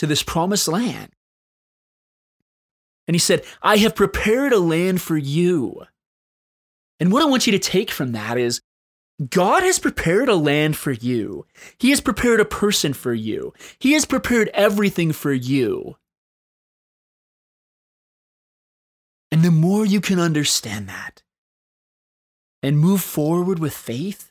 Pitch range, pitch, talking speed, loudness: 145-210 Hz, 175 Hz, 140 wpm, -19 LUFS